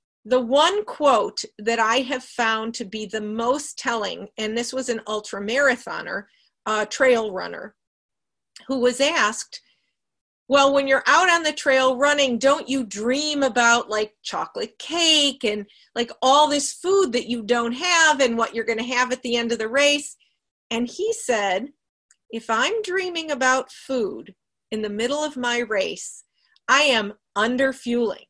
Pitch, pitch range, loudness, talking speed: 255 Hz, 225-280 Hz, -21 LUFS, 160 wpm